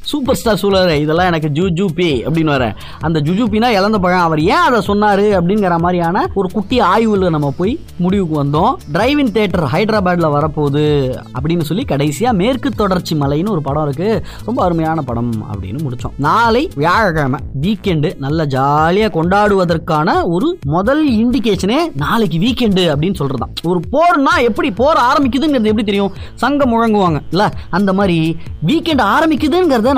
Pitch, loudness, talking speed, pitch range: 185 Hz, -14 LUFS, 145 wpm, 155-220 Hz